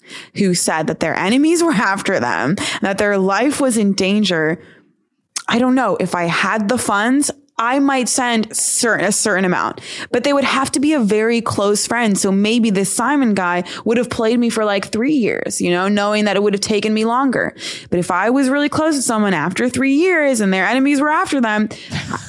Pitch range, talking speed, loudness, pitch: 195-265 Hz, 215 wpm, -16 LUFS, 220 Hz